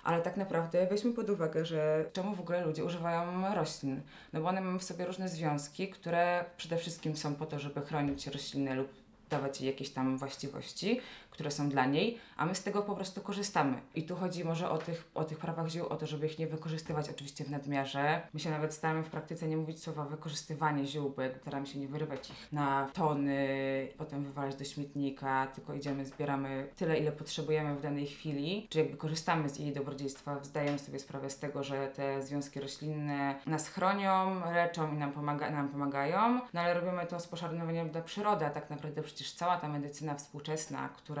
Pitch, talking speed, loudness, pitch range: 155 Hz, 200 wpm, -36 LUFS, 140-170 Hz